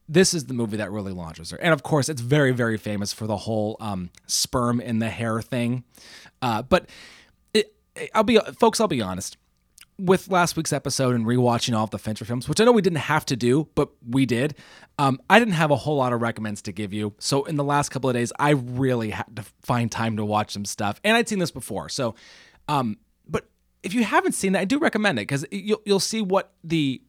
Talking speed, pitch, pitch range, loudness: 235 wpm, 130 Hz, 110-170 Hz, -23 LUFS